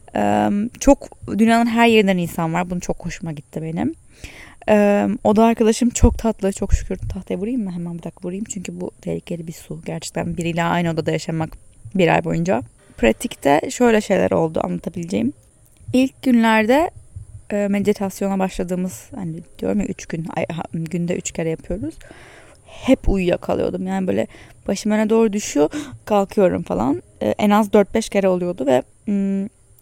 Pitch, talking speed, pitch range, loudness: 190 Hz, 150 wpm, 165-215 Hz, -20 LUFS